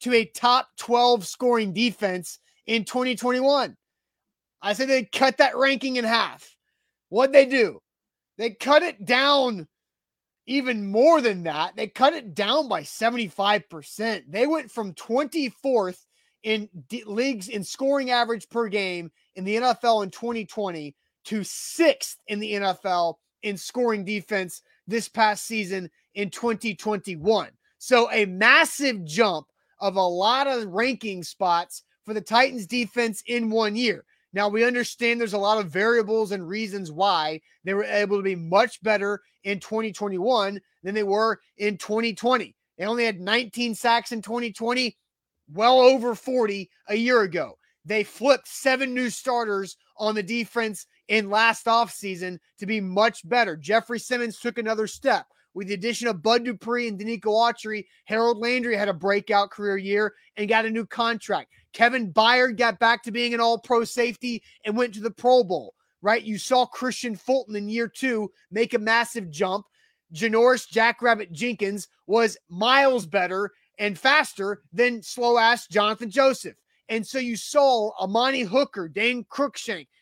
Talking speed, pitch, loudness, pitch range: 155 wpm, 225 Hz, -23 LUFS, 205-245 Hz